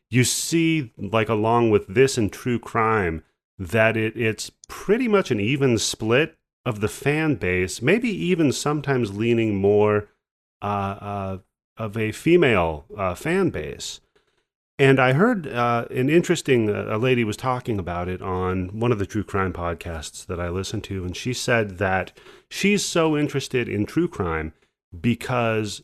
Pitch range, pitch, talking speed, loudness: 100-130 Hz, 110 Hz, 160 wpm, -22 LUFS